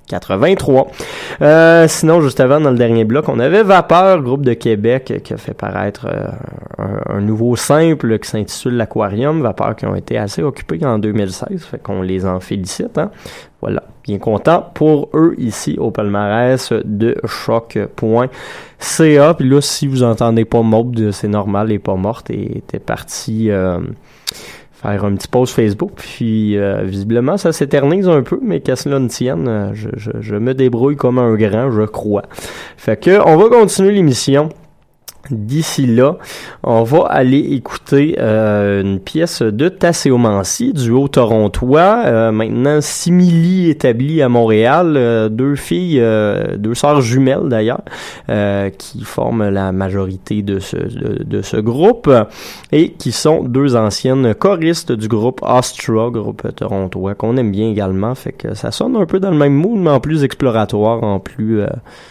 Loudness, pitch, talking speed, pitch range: -14 LUFS, 120 Hz, 165 wpm, 105-145 Hz